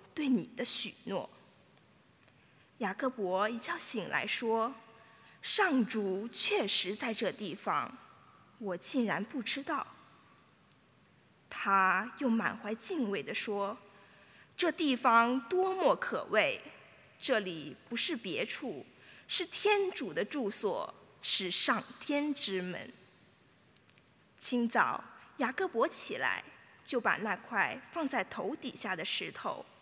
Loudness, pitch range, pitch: -32 LUFS, 205-290 Hz, 235 Hz